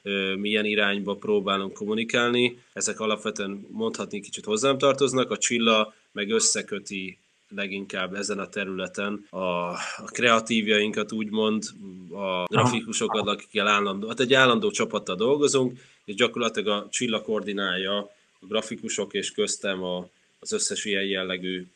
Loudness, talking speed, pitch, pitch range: -25 LUFS, 120 wpm, 105 Hz, 100-115 Hz